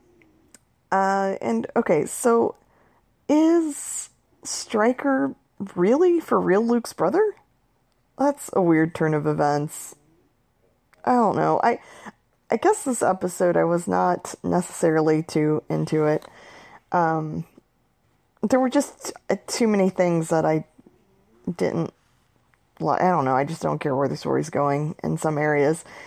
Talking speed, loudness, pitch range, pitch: 135 wpm, -23 LUFS, 150-235 Hz, 175 Hz